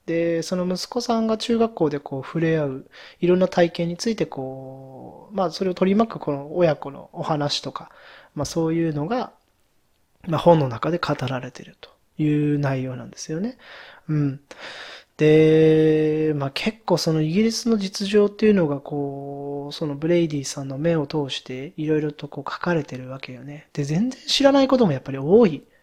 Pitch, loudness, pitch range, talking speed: 155 Hz, -22 LUFS, 145-185 Hz, 350 characters per minute